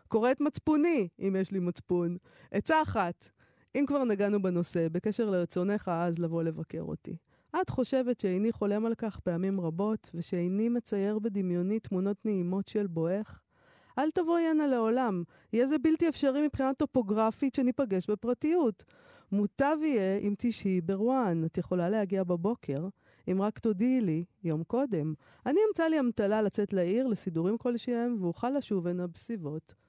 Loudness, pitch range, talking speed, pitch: -31 LUFS, 180-245 Hz, 145 wpm, 205 Hz